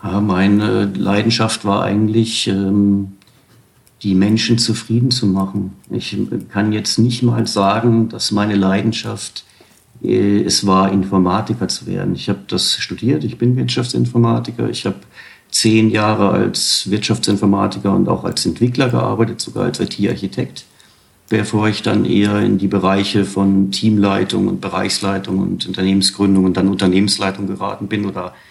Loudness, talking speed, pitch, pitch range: -16 LUFS, 135 wpm, 100 Hz, 95-110 Hz